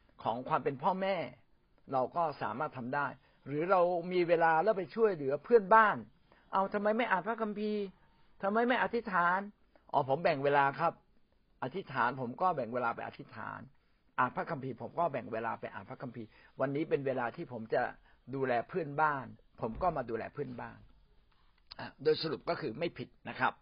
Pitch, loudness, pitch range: 160 Hz, -33 LUFS, 130-195 Hz